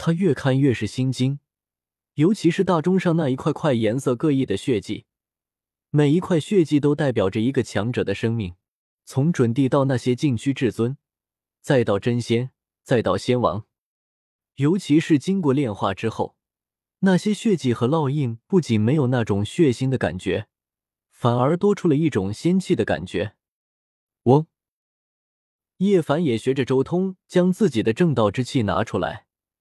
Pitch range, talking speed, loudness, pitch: 115-165 Hz, 235 characters per minute, -21 LUFS, 130 Hz